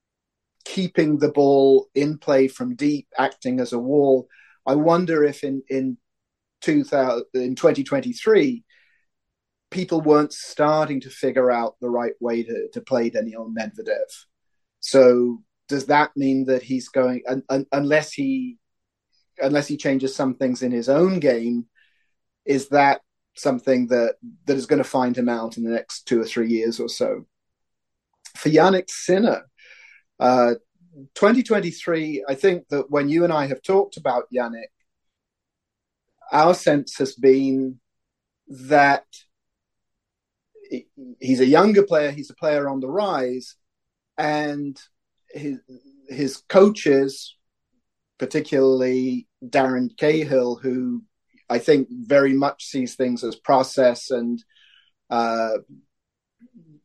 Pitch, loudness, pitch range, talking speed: 135 Hz, -21 LUFS, 125-155 Hz, 130 wpm